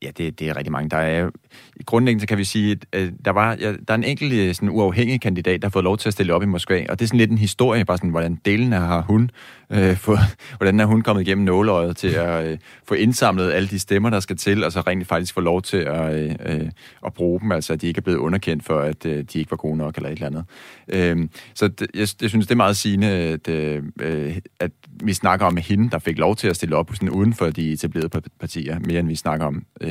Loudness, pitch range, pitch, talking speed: -21 LUFS, 80-105 Hz, 95 Hz, 260 wpm